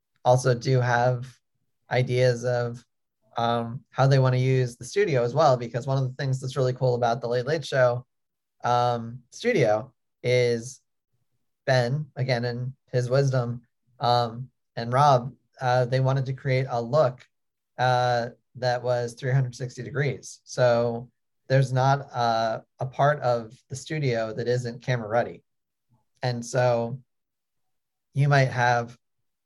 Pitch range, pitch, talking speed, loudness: 120-130 Hz, 125 Hz, 140 wpm, -25 LUFS